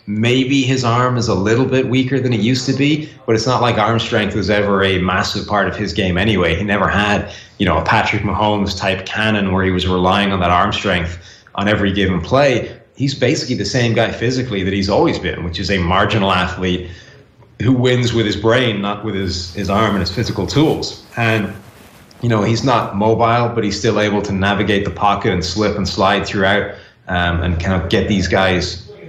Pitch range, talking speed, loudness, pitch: 95-115 Hz, 215 wpm, -16 LUFS, 105 Hz